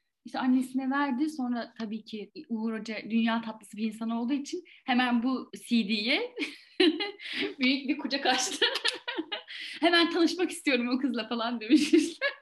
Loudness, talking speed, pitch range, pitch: -29 LUFS, 140 wpm, 230-325 Hz, 265 Hz